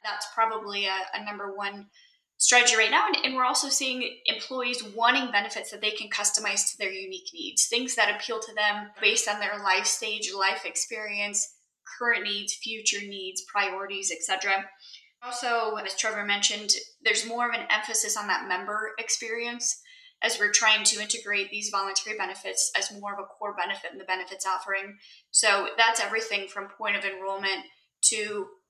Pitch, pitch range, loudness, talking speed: 210 Hz, 200-230 Hz, -26 LUFS, 170 wpm